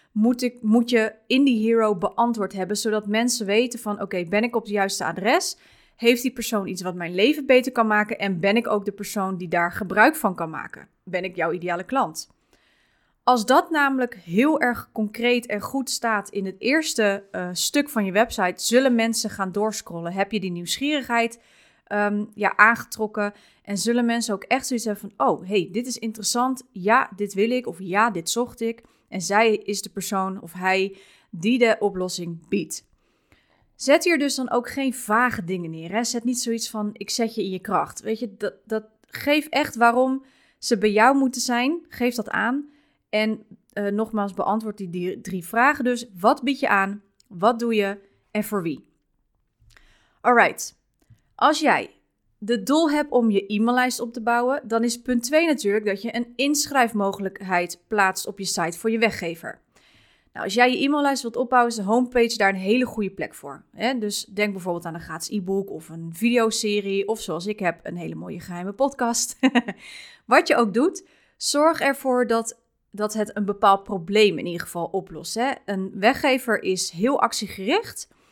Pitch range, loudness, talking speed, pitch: 195-245 Hz, -23 LUFS, 190 wpm, 220 Hz